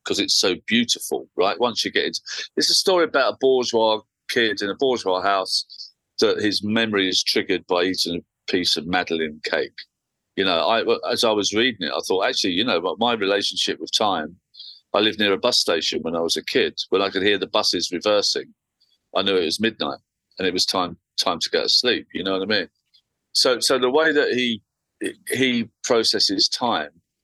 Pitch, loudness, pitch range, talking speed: 105 Hz, -21 LUFS, 95-130 Hz, 210 wpm